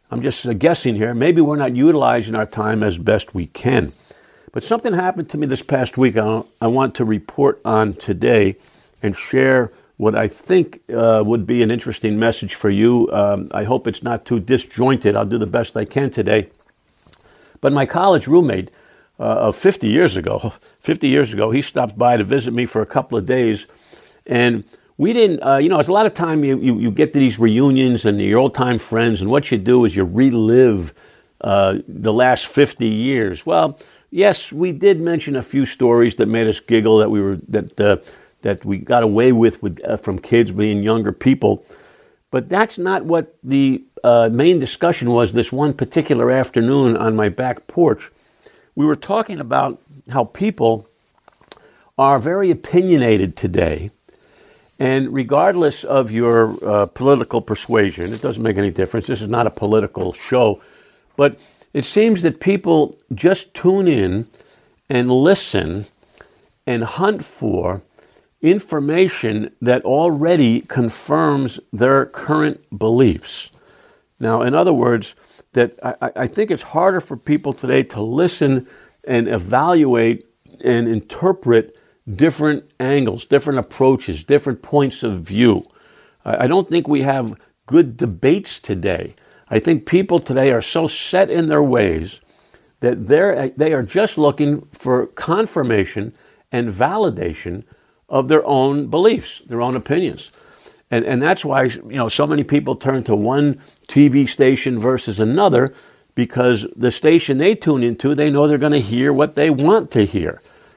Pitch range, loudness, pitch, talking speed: 115-150 Hz, -17 LUFS, 130 Hz, 165 wpm